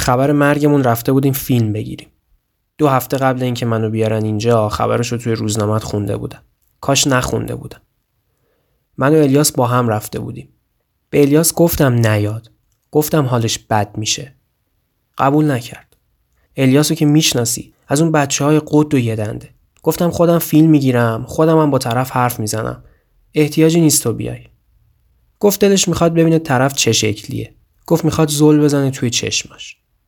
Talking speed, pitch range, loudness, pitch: 150 wpm, 110-150 Hz, -15 LUFS, 130 Hz